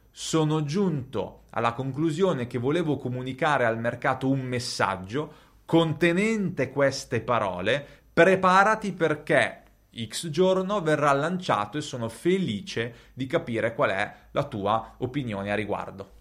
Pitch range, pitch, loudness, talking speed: 115-165 Hz, 135 Hz, -26 LUFS, 120 wpm